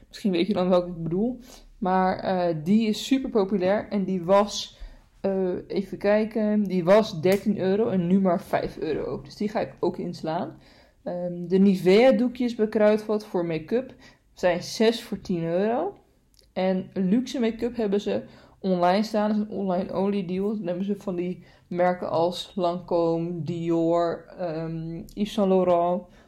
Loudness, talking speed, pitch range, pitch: -25 LUFS, 165 wpm, 180-210 Hz, 190 Hz